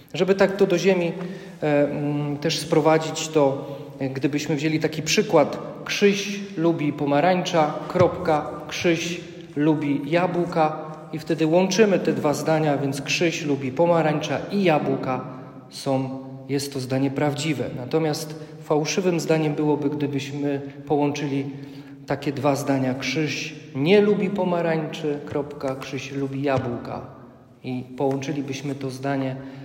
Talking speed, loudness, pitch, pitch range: 120 wpm, -23 LUFS, 150 Hz, 140-160 Hz